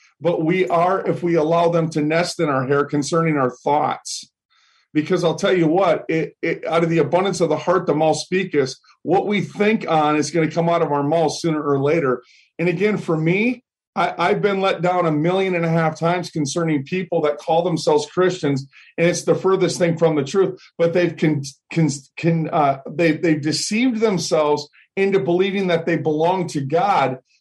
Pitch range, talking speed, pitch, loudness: 155-180 Hz, 205 wpm, 165 Hz, -19 LUFS